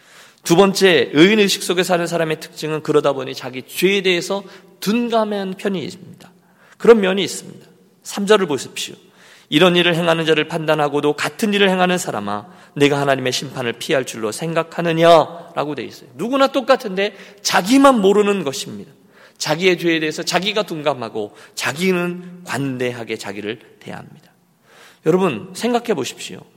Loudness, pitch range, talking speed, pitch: -17 LUFS, 150-195 Hz, 355 characters per minute, 175 Hz